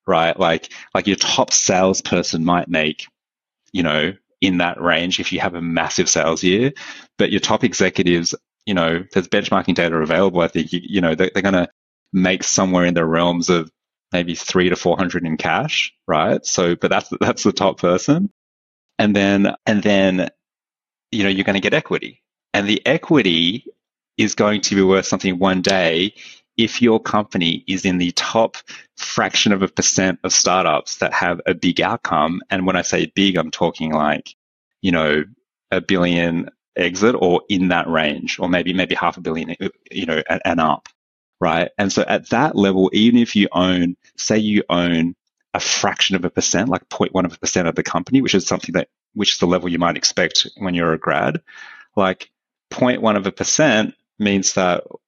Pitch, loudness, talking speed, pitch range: 90 Hz, -18 LUFS, 190 wpm, 85-95 Hz